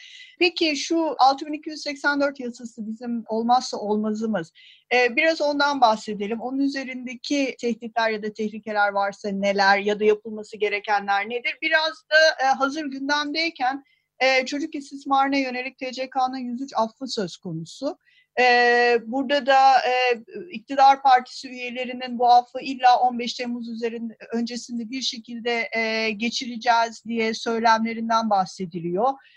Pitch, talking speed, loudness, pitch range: 245 Hz, 120 wpm, -22 LUFS, 225-275 Hz